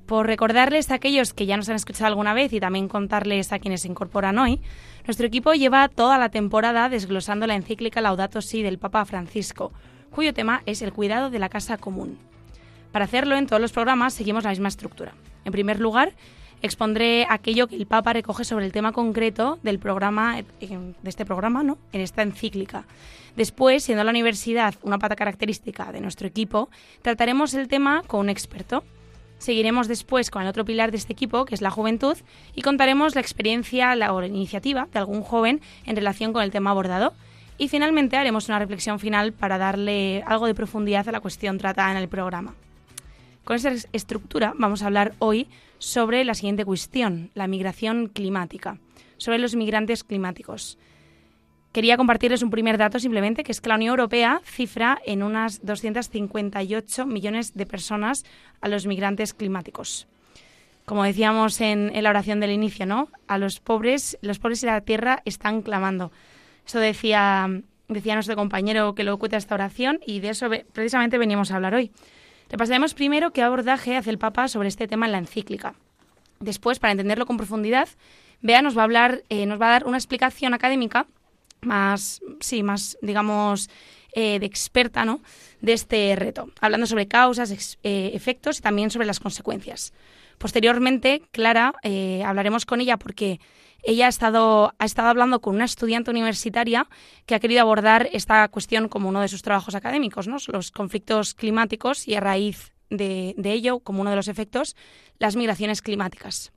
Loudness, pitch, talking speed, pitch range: -23 LUFS, 220 Hz, 180 wpm, 205-240 Hz